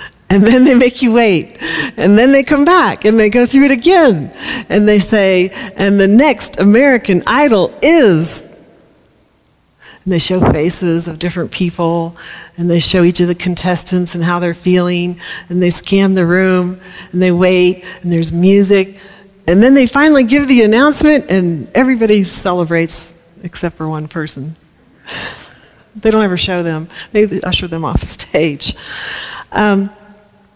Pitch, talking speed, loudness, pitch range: 185 Hz, 160 wpm, -11 LUFS, 175-215 Hz